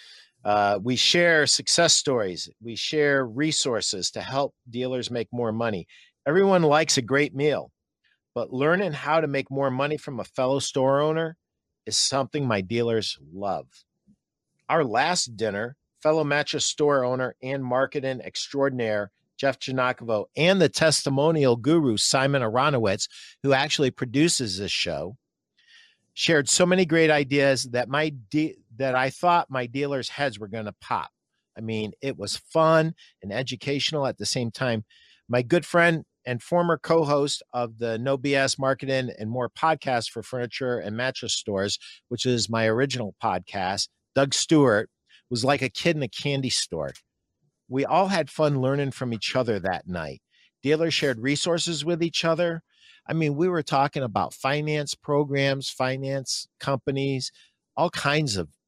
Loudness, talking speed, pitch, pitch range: -24 LUFS, 155 wpm, 135 Hz, 120-150 Hz